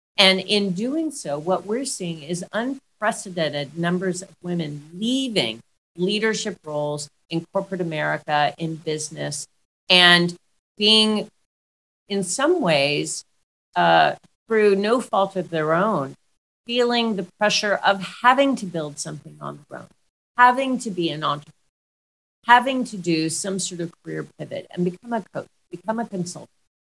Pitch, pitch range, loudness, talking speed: 185 Hz, 155-215 Hz, -21 LUFS, 140 wpm